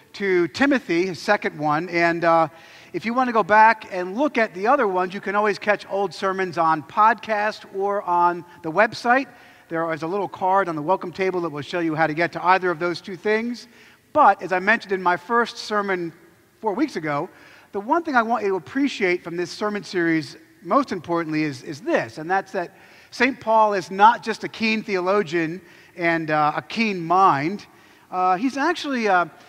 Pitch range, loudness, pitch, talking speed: 170-220 Hz, -21 LUFS, 190 Hz, 205 wpm